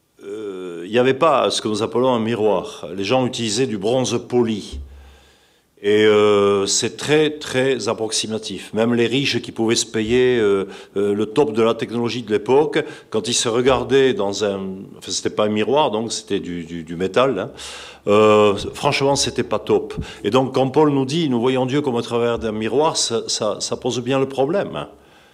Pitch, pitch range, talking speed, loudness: 115 Hz, 105-130 Hz, 200 wpm, -19 LUFS